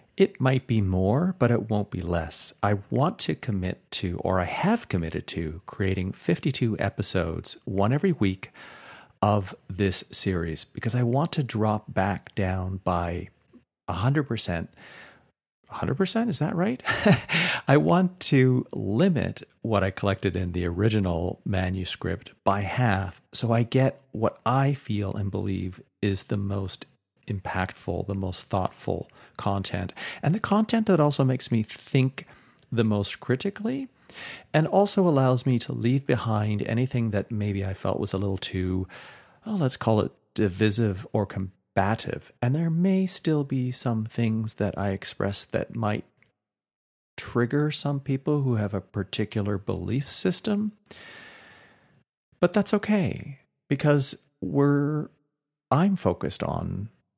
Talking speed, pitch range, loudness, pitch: 140 wpm, 100-145 Hz, -26 LUFS, 115 Hz